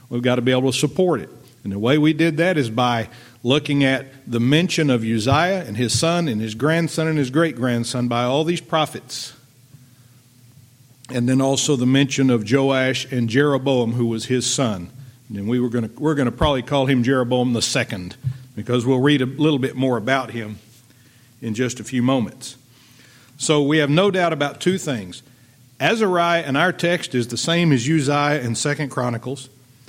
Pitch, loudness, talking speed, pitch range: 130 Hz, -20 LUFS, 195 wpm, 125-145 Hz